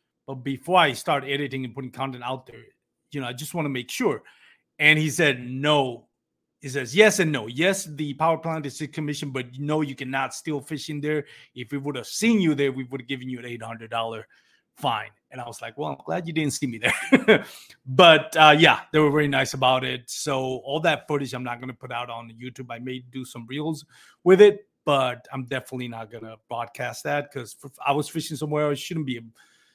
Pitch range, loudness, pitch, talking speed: 125-155 Hz, -23 LUFS, 140 Hz, 230 wpm